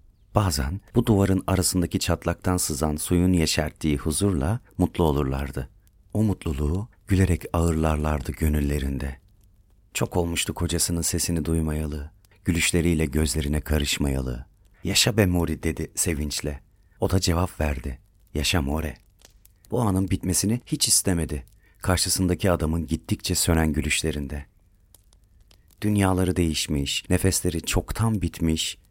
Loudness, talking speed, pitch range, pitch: -24 LUFS, 105 wpm, 75-95 Hz, 85 Hz